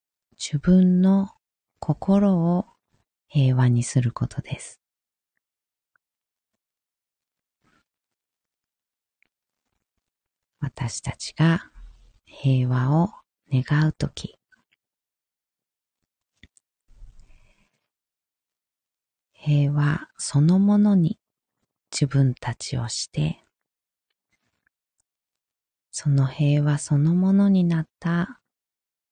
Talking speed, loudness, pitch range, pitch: 105 characters per minute, -22 LUFS, 120-170 Hz, 145 Hz